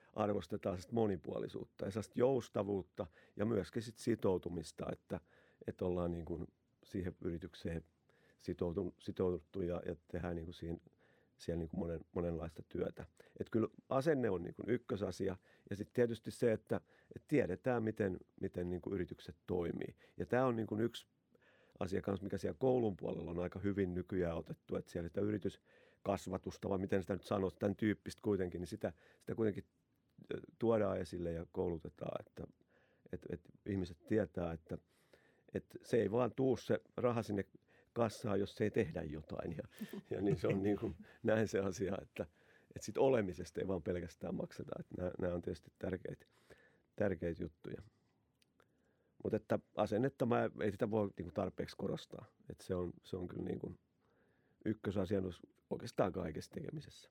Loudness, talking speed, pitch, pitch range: -41 LUFS, 150 wpm, 95 Hz, 90-110 Hz